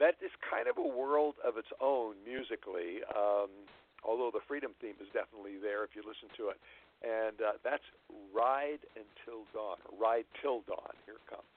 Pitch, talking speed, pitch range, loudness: 115 Hz, 180 wpm, 105-150 Hz, -37 LUFS